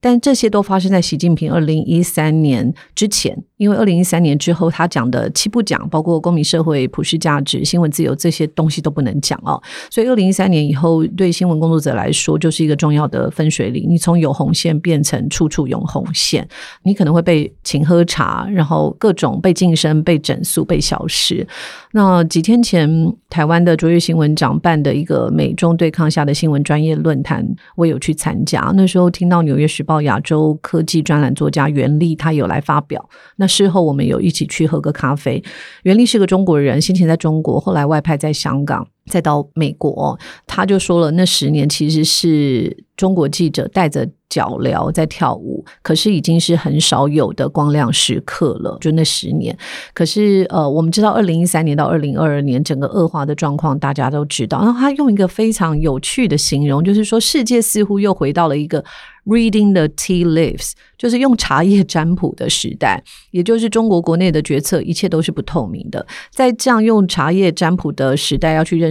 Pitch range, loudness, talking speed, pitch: 150-185 Hz, -15 LUFS, 320 characters per minute, 165 Hz